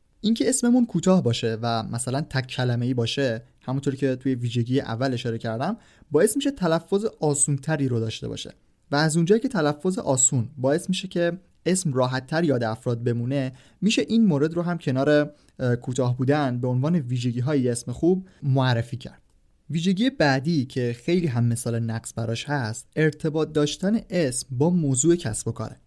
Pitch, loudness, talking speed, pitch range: 140 Hz, -24 LUFS, 160 wpm, 125-170 Hz